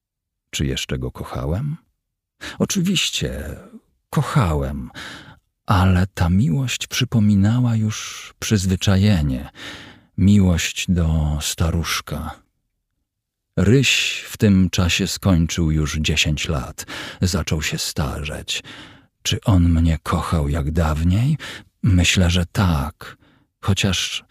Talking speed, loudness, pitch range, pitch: 90 wpm, -20 LUFS, 80-105 Hz, 90 Hz